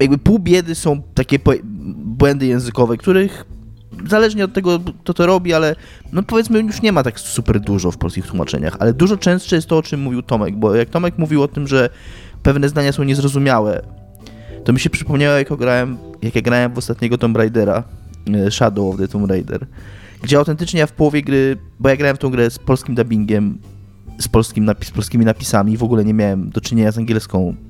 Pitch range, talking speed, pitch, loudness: 105-145 Hz, 205 wpm, 120 Hz, -16 LUFS